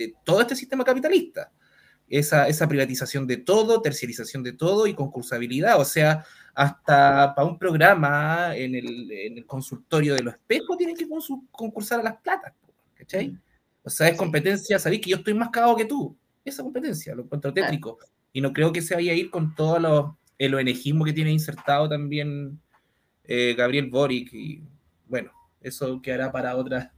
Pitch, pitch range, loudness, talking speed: 150 Hz, 135-200 Hz, -23 LUFS, 175 wpm